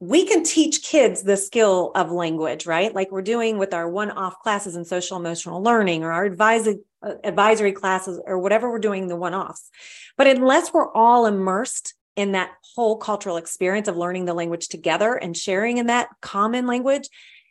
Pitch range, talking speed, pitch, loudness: 180-230 Hz, 180 wpm, 200 Hz, -21 LUFS